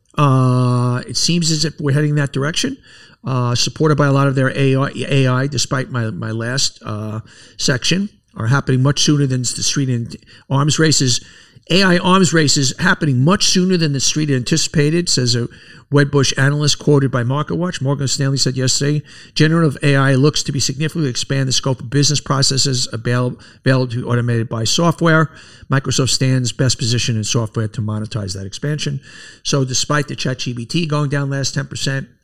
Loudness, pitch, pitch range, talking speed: -16 LUFS, 135 Hz, 125-150 Hz, 175 wpm